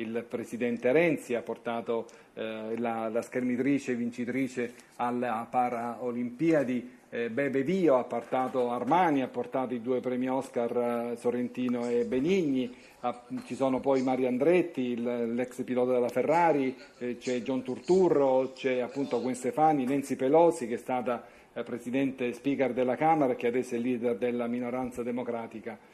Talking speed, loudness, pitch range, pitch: 150 wpm, -29 LUFS, 120-130 Hz, 125 Hz